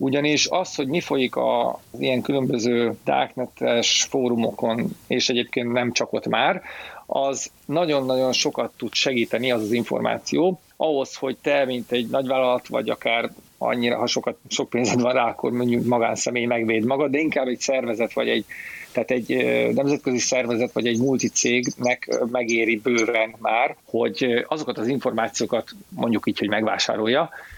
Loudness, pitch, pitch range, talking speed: -22 LUFS, 125 Hz, 120-135 Hz, 150 wpm